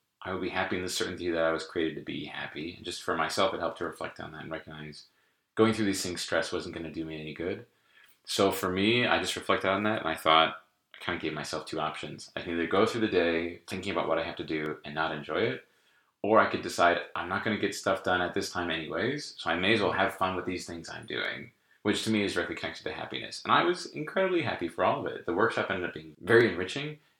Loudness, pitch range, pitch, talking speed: -30 LUFS, 80-105 Hz, 90 Hz, 275 wpm